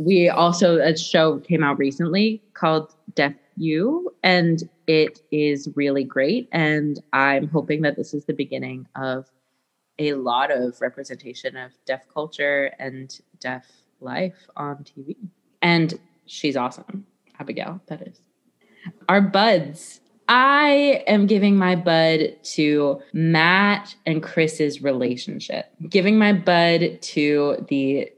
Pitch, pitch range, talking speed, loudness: 160 Hz, 140-185 Hz, 125 wpm, -20 LUFS